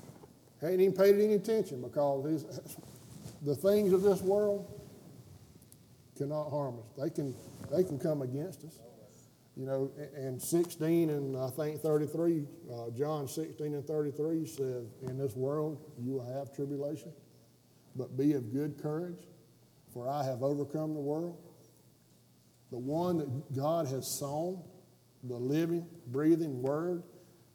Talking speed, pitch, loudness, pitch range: 140 wpm, 145 Hz, -34 LUFS, 130-165 Hz